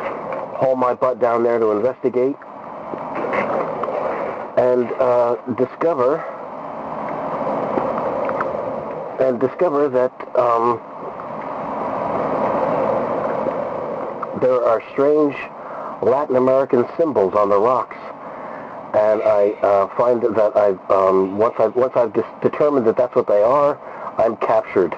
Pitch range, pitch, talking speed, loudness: 115-135 Hz, 125 Hz, 105 wpm, -19 LUFS